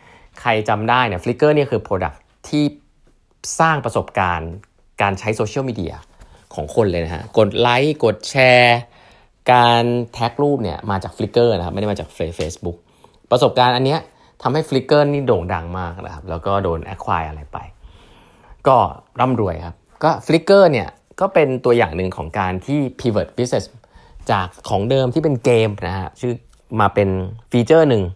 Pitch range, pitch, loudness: 90-125 Hz, 110 Hz, -18 LUFS